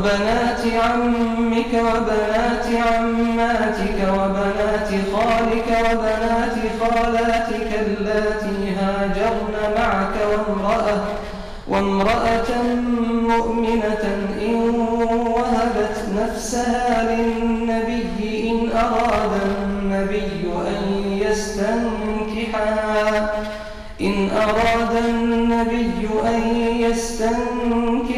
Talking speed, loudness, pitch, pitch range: 60 wpm, -20 LUFS, 225 Hz, 210-230 Hz